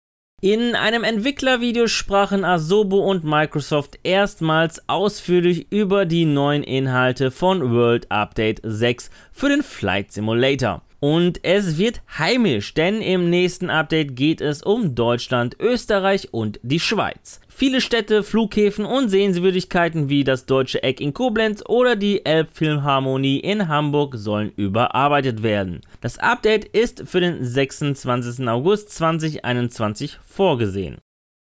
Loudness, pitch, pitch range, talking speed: -20 LUFS, 160 Hz, 130-200 Hz, 125 wpm